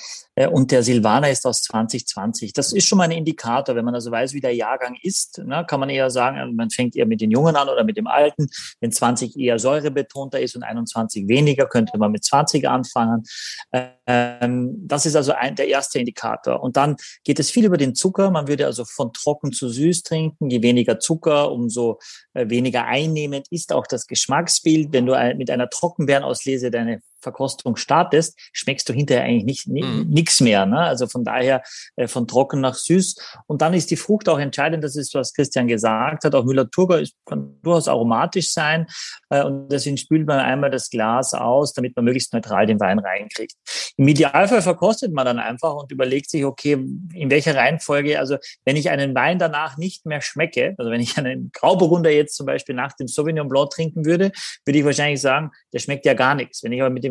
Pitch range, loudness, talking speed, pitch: 125-155 Hz, -19 LUFS, 200 wpm, 140 Hz